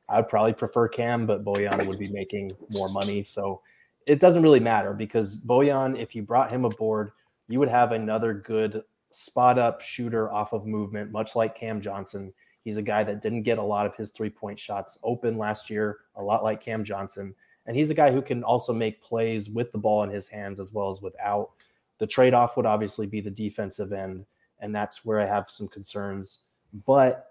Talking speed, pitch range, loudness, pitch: 210 wpm, 100-115 Hz, -26 LUFS, 110 Hz